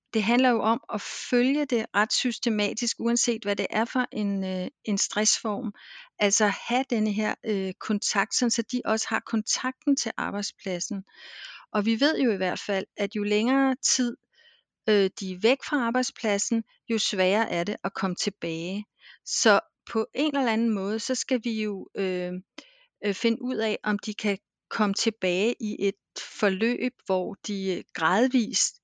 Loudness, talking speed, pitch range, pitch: -26 LUFS, 165 wpm, 200-240 Hz, 220 Hz